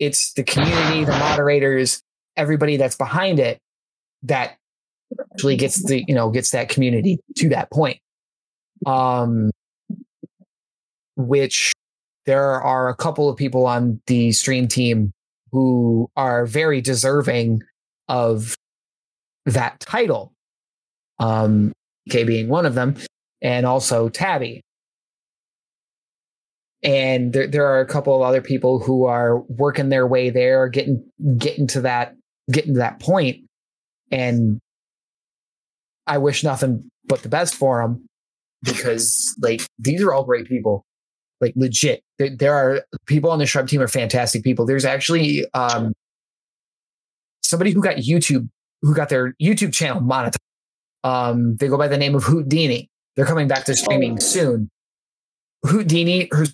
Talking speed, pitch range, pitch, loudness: 140 wpm, 125-145 Hz, 130 Hz, -19 LUFS